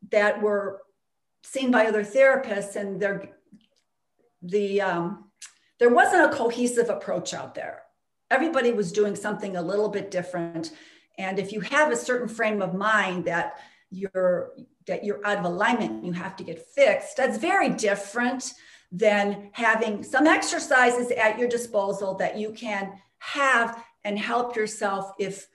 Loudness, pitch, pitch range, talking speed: -24 LUFS, 210 Hz, 195-240 Hz, 150 wpm